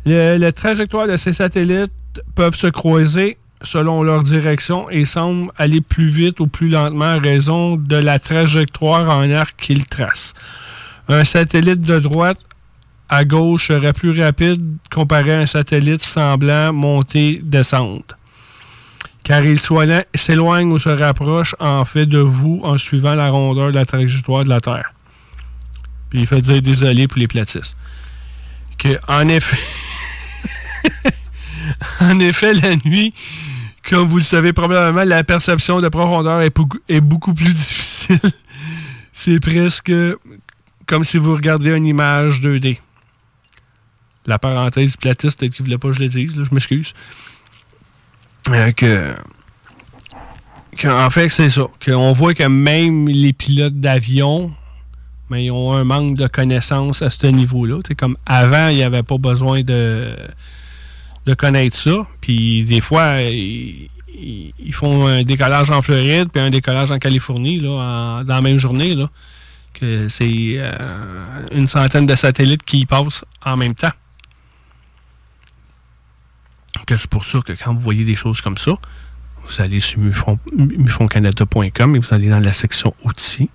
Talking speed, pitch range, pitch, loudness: 150 wpm, 120-155 Hz, 140 Hz, -14 LUFS